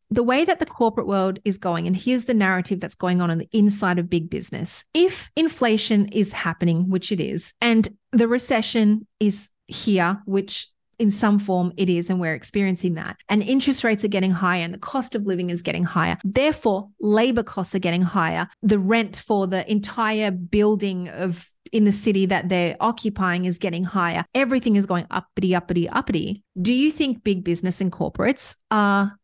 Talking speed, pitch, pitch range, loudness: 190 wpm, 200 Hz, 180-225 Hz, -22 LUFS